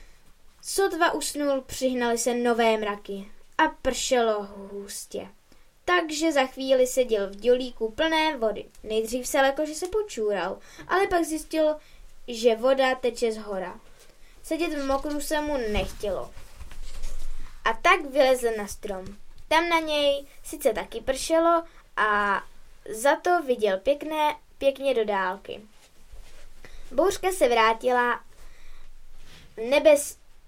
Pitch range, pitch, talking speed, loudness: 225-310 Hz, 265 Hz, 120 wpm, -25 LUFS